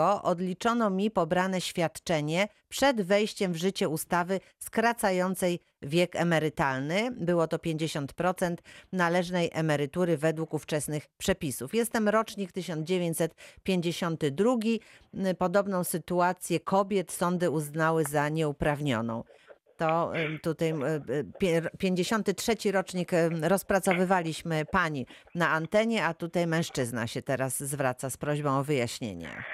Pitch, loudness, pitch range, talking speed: 175 Hz, -29 LUFS, 155-190 Hz, 95 wpm